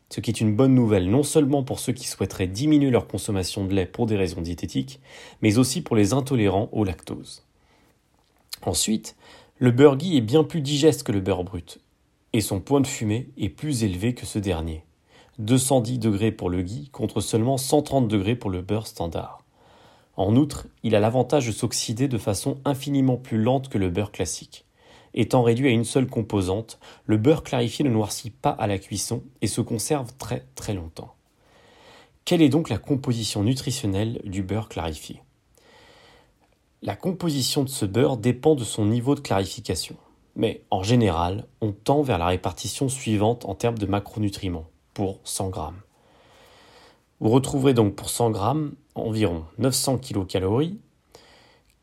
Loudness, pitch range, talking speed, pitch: -24 LUFS, 100-135 Hz, 170 wpm, 115 Hz